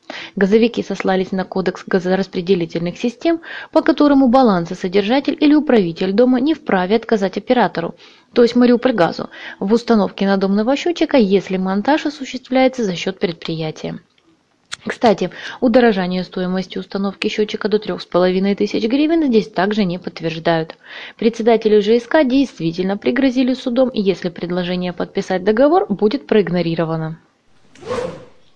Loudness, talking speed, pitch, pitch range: -17 LUFS, 115 wpm, 215 Hz, 185-255 Hz